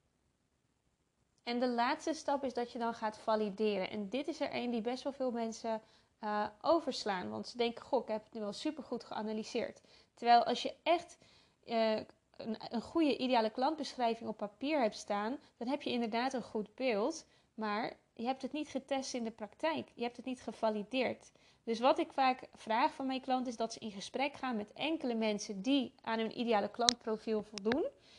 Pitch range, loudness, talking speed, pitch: 220-265 Hz, -36 LUFS, 195 wpm, 240 Hz